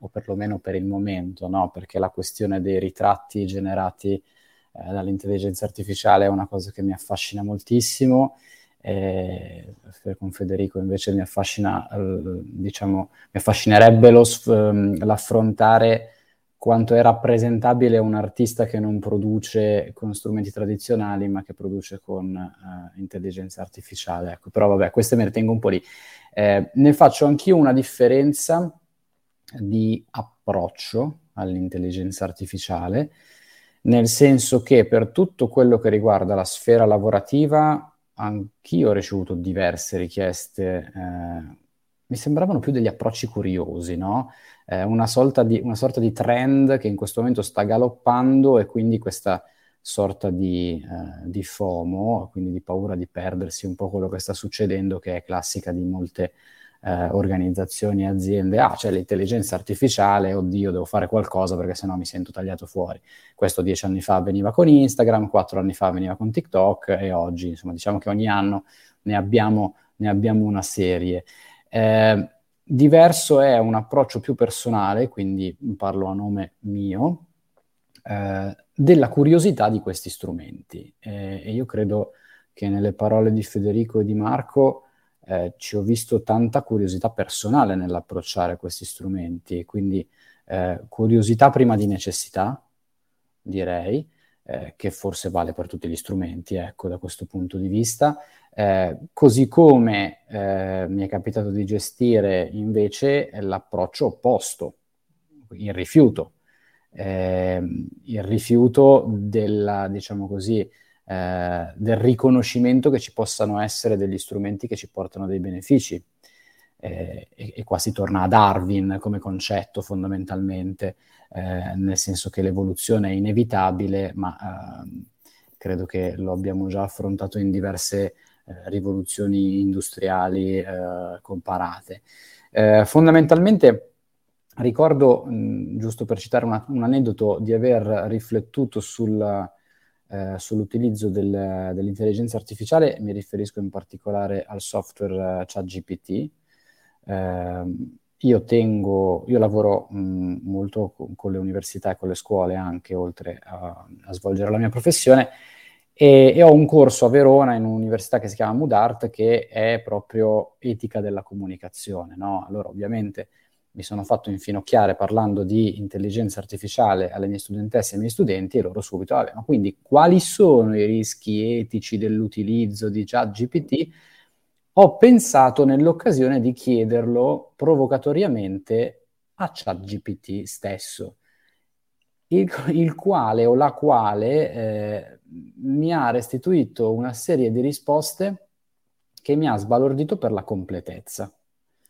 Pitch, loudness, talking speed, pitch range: 100 Hz, -20 LUFS, 135 wpm, 95-115 Hz